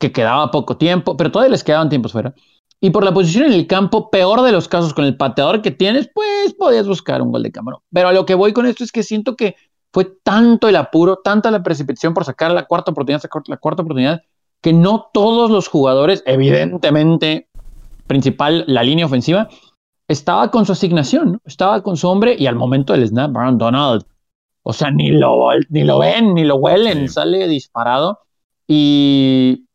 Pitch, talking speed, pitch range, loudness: 170 Hz, 200 wpm, 140-200 Hz, -14 LUFS